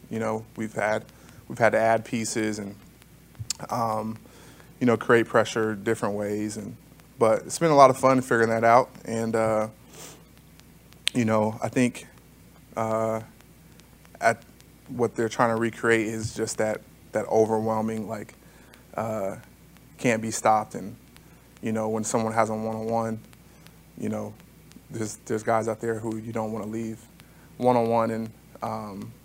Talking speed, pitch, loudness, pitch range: 155 wpm, 110 Hz, -25 LUFS, 110-115 Hz